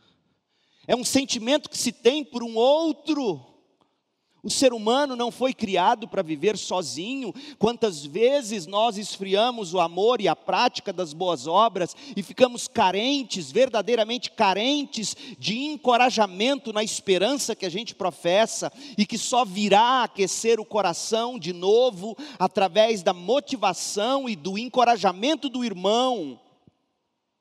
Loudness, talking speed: -24 LUFS, 130 wpm